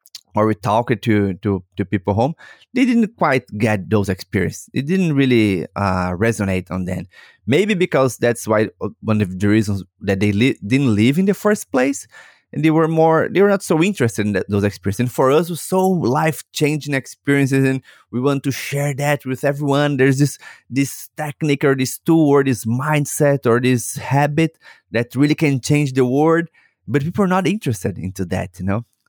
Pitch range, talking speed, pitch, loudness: 105-150 Hz, 200 wpm, 130 Hz, -18 LUFS